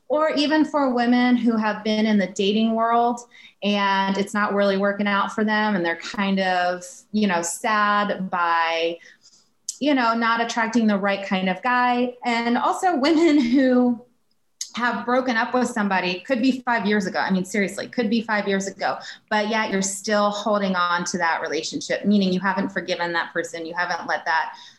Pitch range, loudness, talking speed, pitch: 195-240 Hz, -21 LUFS, 185 wpm, 210 Hz